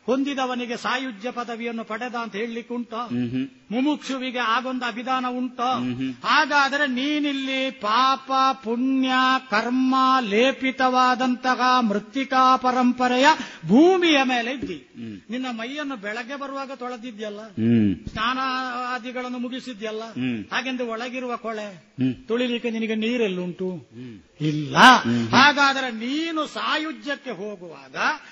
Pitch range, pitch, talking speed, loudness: 225-260 Hz, 250 Hz, 85 wpm, -22 LUFS